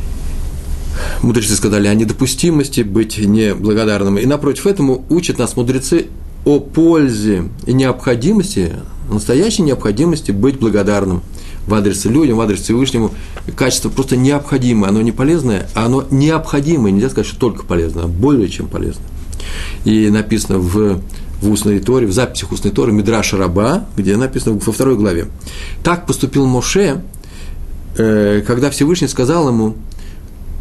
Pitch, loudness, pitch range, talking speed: 110 Hz, -14 LUFS, 90-130 Hz, 135 wpm